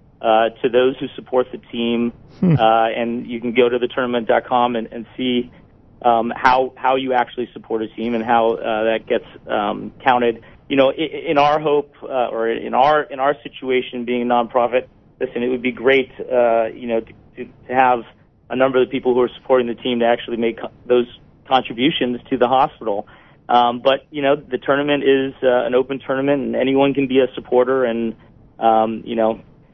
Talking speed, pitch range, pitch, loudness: 210 wpm, 115-135 Hz, 125 Hz, -18 LUFS